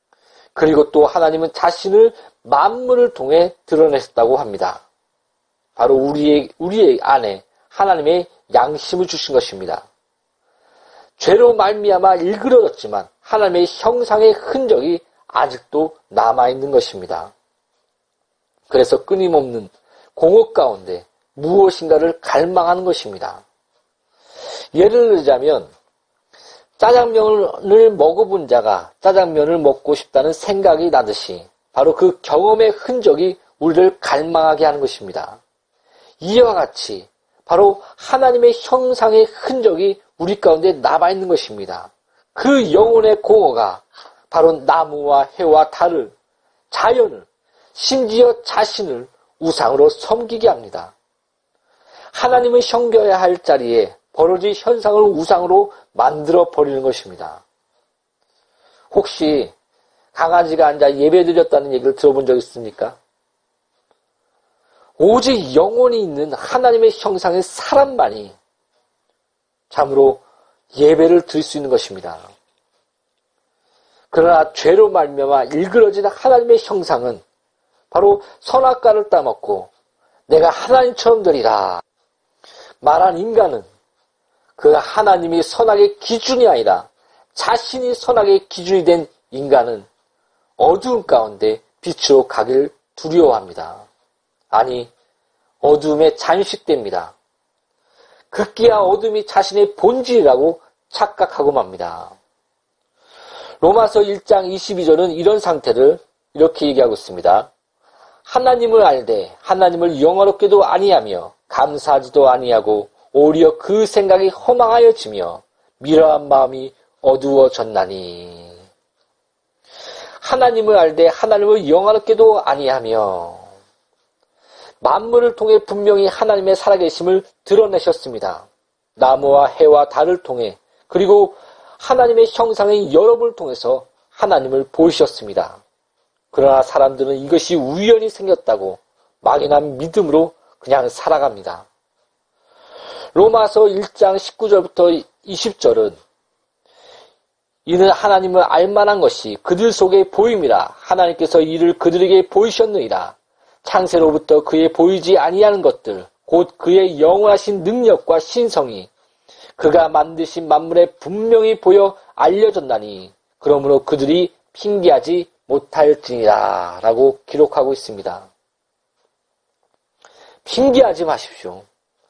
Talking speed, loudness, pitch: 255 characters per minute, -14 LUFS, 205 Hz